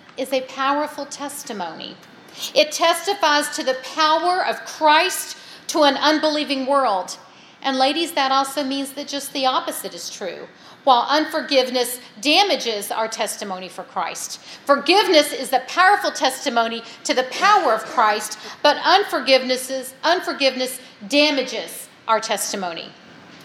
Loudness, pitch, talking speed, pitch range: -19 LUFS, 275 Hz, 125 wpm, 255-305 Hz